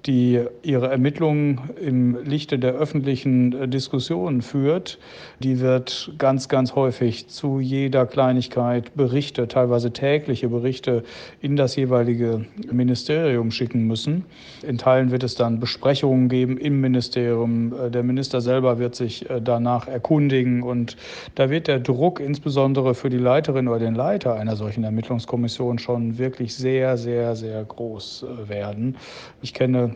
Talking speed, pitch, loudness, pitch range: 135 wpm, 125 Hz, -22 LUFS, 120-135 Hz